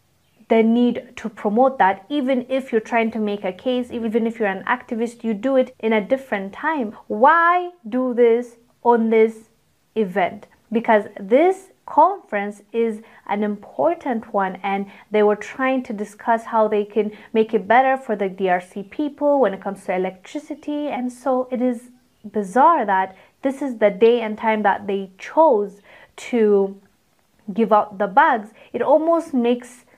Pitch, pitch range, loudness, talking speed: 230 Hz, 210-255 Hz, -20 LUFS, 165 wpm